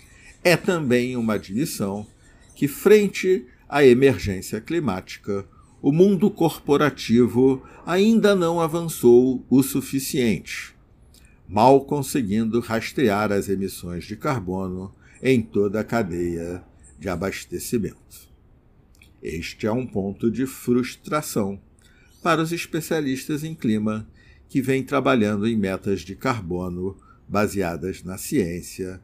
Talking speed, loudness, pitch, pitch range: 105 wpm, -22 LUFS, 115 Hz, 95-140 Hz